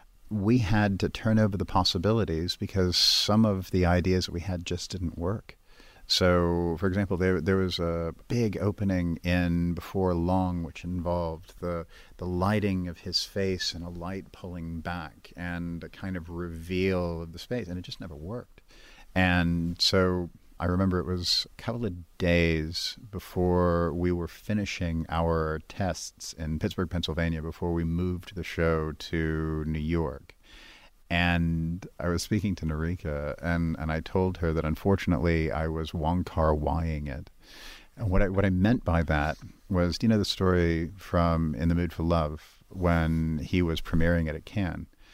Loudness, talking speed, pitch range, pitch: -28 LUFS, 170 wpm, 85-95 Hz, 85 Hz